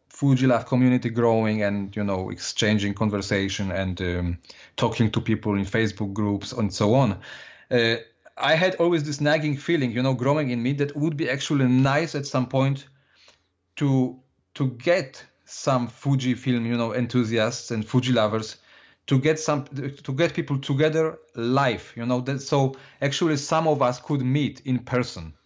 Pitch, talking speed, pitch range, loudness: 130 Hz, 170 wpm, 115-145 Hz, -24 LUFS